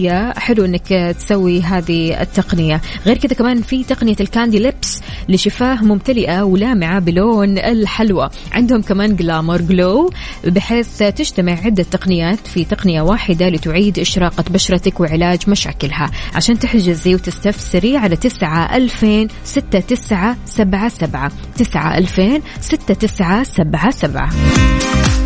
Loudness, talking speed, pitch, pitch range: -14 LUFS, 115 wpm, 195 Hz, 175-225 Hz